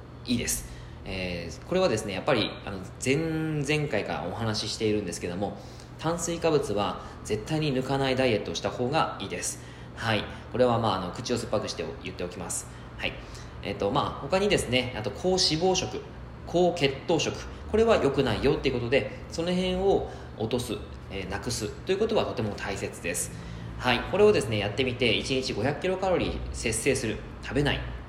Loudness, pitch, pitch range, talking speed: -28 LUFS, 120 Hz, 95-145 Hz, 375 characters per minute